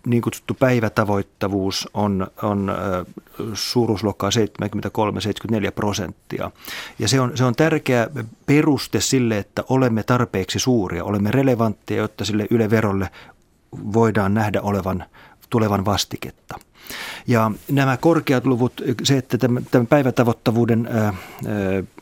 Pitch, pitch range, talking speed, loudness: 110 Hz, 100-125 Hz, 110 wpm, -20 LUFS